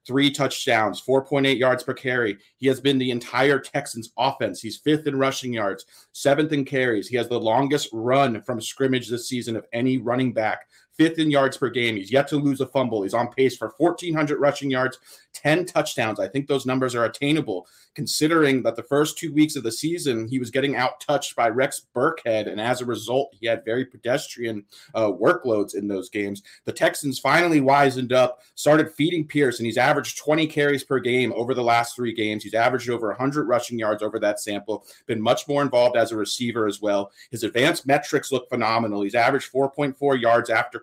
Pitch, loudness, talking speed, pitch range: 130 Hz, -23 LUFS, 205 wpm, 115-140 Hz